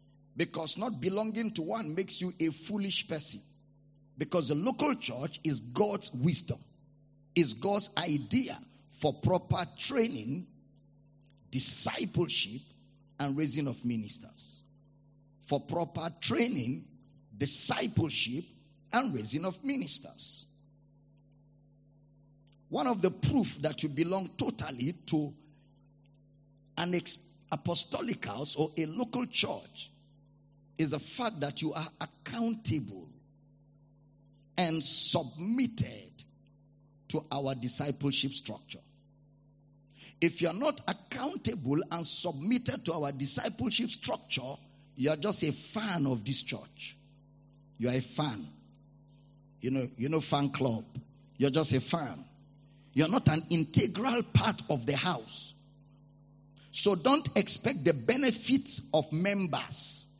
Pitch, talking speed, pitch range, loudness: 145 Hz, 110 wpm, 145-170 Hz, -32 LUFS